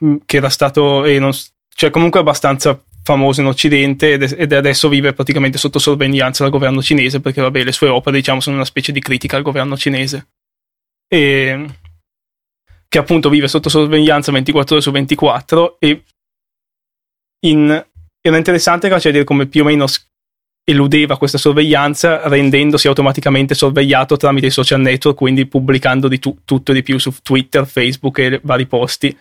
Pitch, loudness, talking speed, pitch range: 140 Hz, -12 LUFS, 165 wpm, 135-150 Hz